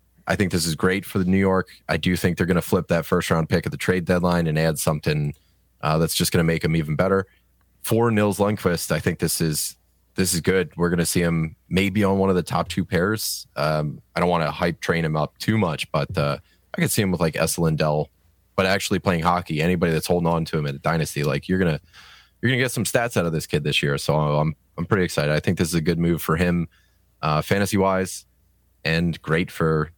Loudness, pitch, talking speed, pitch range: -22 LUFS, 85 Hz, 255 wpm, 80-95 Hz